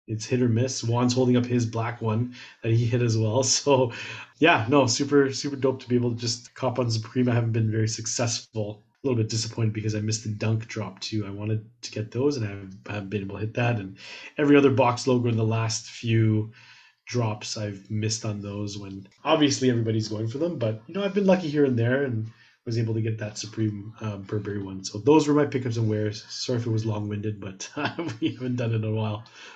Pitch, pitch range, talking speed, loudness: 115 Hz, 110-125 Hz, 245 wpm, -26 LUFS